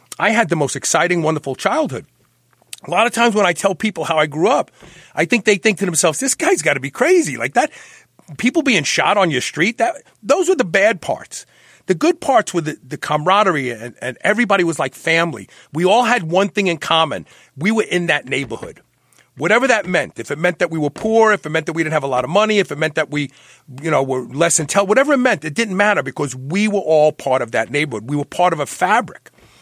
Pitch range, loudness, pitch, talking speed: 150-210 Hz, -17 LUFS, 175 Hz, 245 wpm